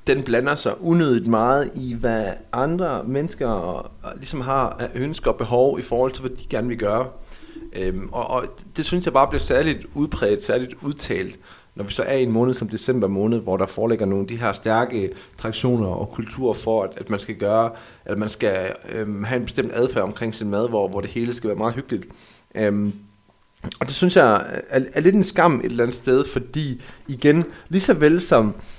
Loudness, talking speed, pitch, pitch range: -22 LUFS, 215 wpm, 120 Hz, 105-135 Hz